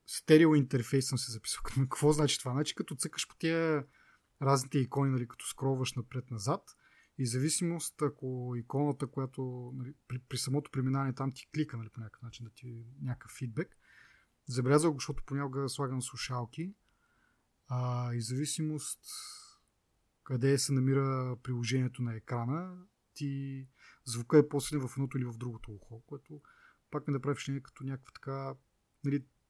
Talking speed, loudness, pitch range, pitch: 155 wpm, -34 LUFS, 125-145 Hz, 135 Hz